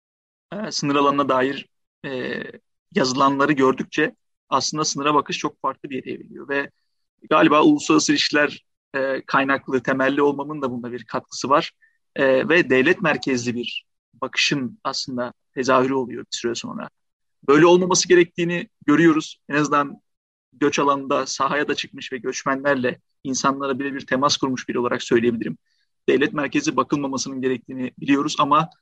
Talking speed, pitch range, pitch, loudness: 135 wpm, 130-150 Hz, 140 Hz, -21 LUFS